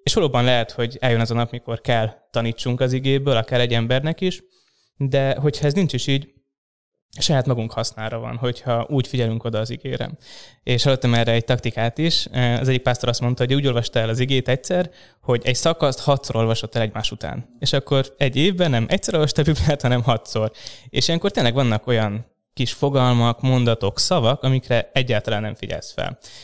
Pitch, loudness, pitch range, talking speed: 125 Hz, -21 LUFS, 115-140 Hz, 190 wpm